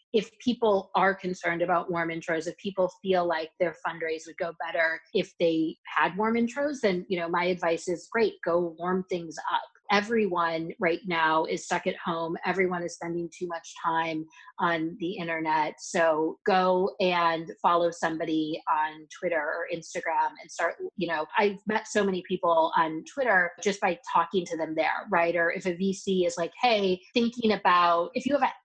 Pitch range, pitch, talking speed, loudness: 165-190 Hz, 175 Hz, 185 wpm, -27 LUFS